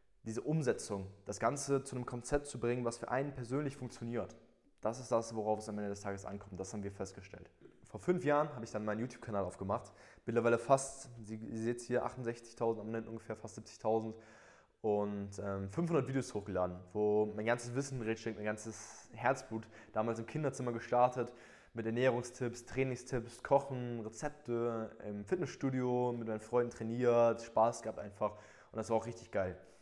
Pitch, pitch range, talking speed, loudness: 115 Hz, 105-125 Hz, 170 wpm, -38 LUFS